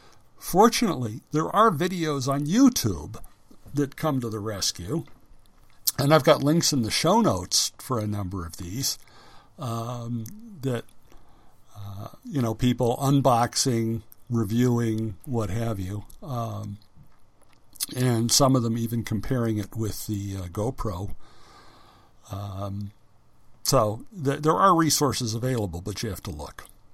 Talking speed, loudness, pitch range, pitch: 130 wpm, -25 LUFS, 105-135 Hz, 115 Hz